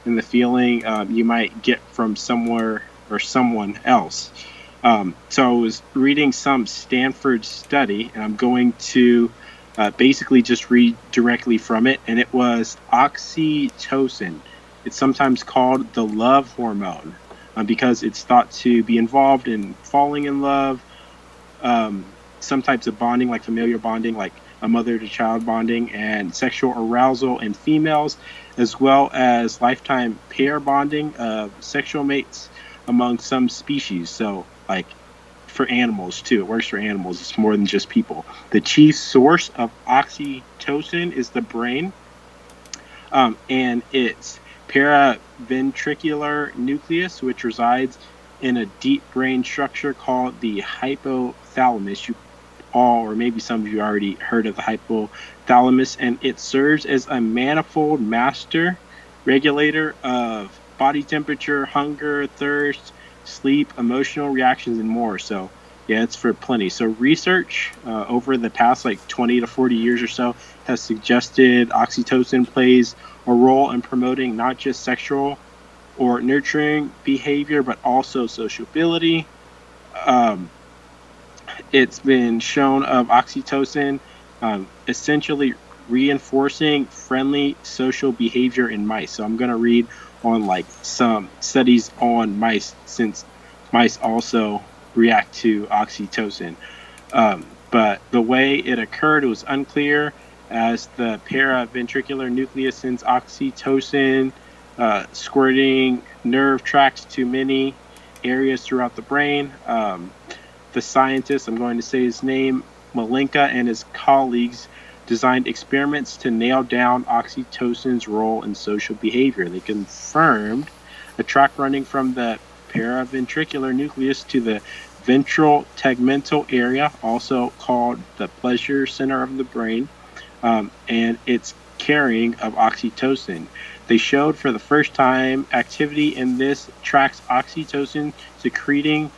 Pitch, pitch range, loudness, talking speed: 125 Hz, 115-140 Hz, -19 LUFS, 130 wpm